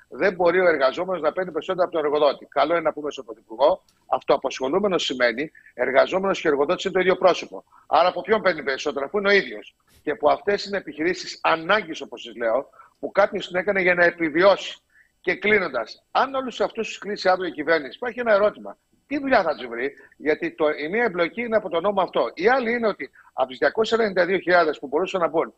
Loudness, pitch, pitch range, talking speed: -22 LUFS, 185 Hz, 160-215 Hz, 210 wpm